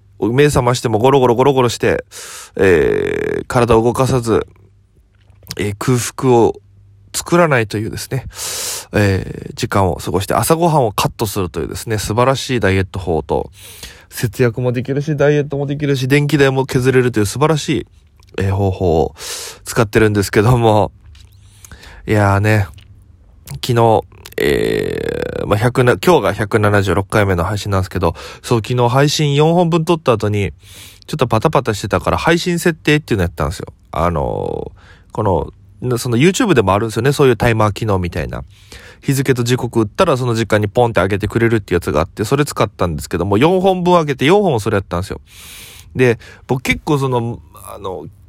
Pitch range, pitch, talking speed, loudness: 95-140 Hz, 115 Hz, 365 characters per minute, -15 LUFS